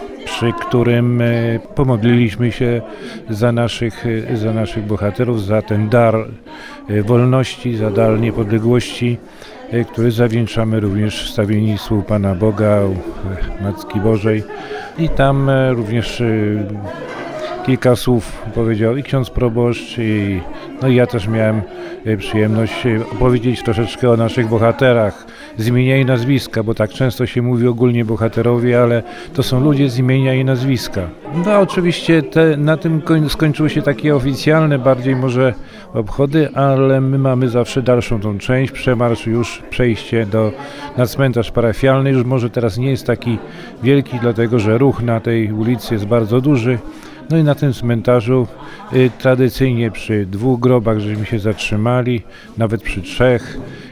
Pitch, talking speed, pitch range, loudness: 120 Hz, 135 wpm, 110-130 Hz, -16 LUFS